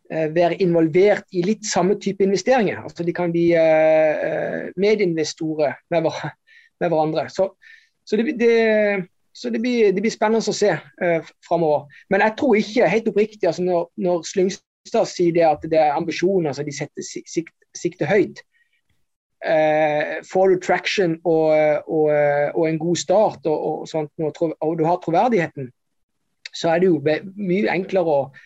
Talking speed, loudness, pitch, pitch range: 160 wpm, -20 LUFS, 175 Hz, 160-205 Hz